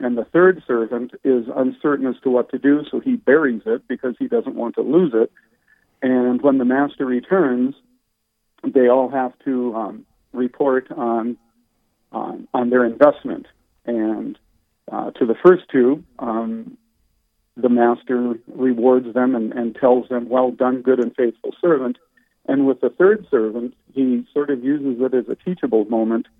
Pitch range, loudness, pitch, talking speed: 120-140 Hz, -19 LUFS, 125 Hz, 165 wpm